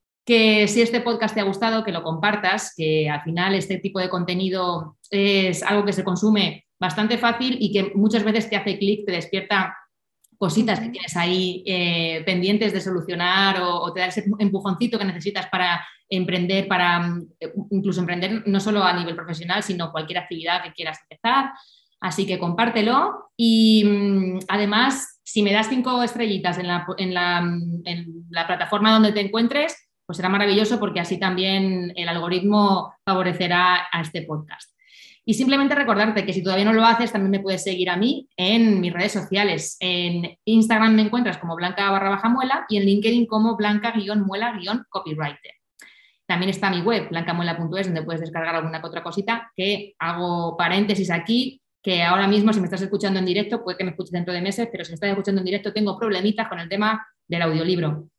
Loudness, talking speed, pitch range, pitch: -21 LUFS, 180 wpm, 180-215 Hz, 195 Hz